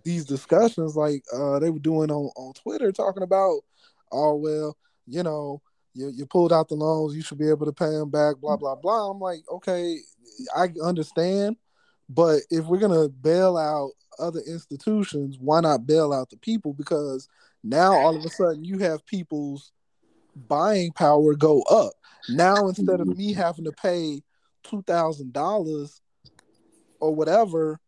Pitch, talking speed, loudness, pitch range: 160 Hz, 165 wpm, -23 LUFS, 150-180 Hz